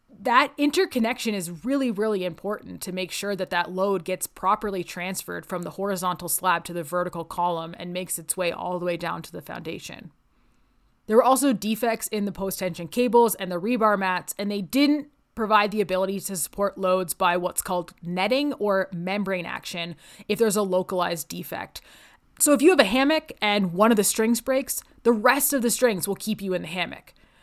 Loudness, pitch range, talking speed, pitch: -24 LUFS, 180-230 Hz, 200 wpm, 195 Hz